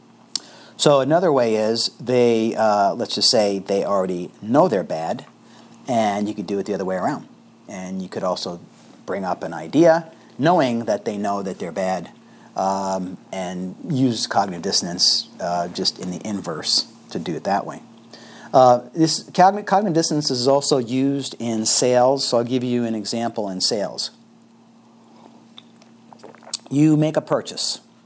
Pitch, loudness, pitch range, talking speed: 115 Hz, -20 LUFS, 100-135 Hz, 160 wpm